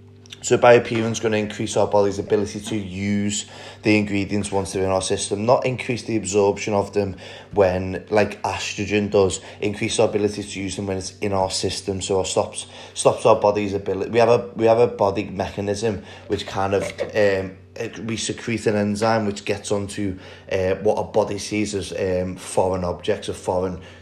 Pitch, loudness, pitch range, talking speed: 100 Hz, -22 LUFS, 95-105 Hz, 190 wpm